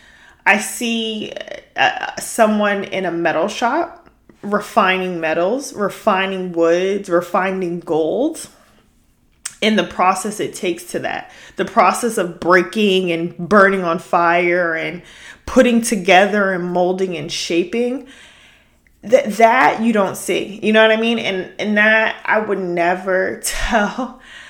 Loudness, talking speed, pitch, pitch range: -17 LUFS, 130 wpm, 195 Hz, 180-220 Hz